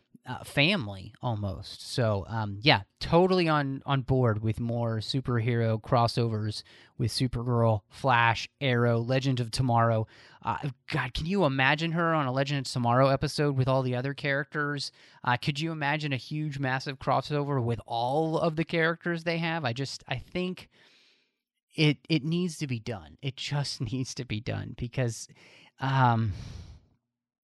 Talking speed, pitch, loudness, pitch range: 155 wpm, 130 Hz, -28 LUFS, 115-150 Hz